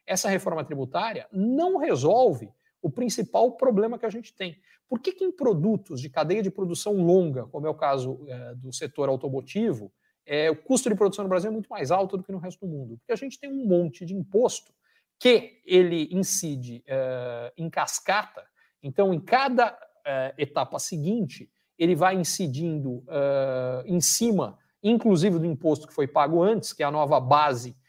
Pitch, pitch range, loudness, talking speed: 175 Hz, 145-215 Hz, -25 LUFS, 185 wpm